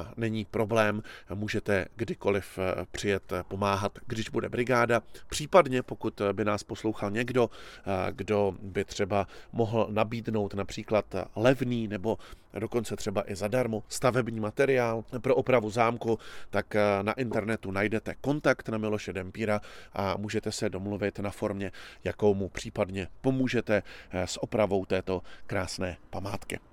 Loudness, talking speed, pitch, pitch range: -30 LUFS, 125 wpm, 105 Hz, 100-115 Hz